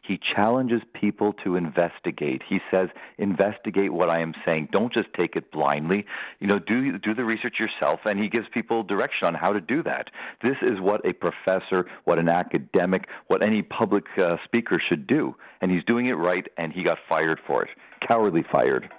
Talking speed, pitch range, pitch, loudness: 195 wpm, 95-115 Hz, 105 Hz, -25 LUFS